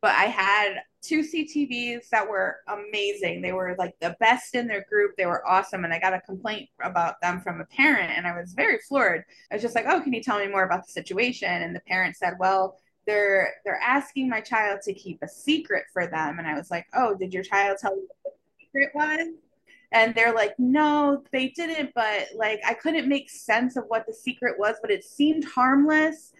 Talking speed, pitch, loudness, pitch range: 225 wpm, 215 Hz, -25 LUFS, 185-275 Hz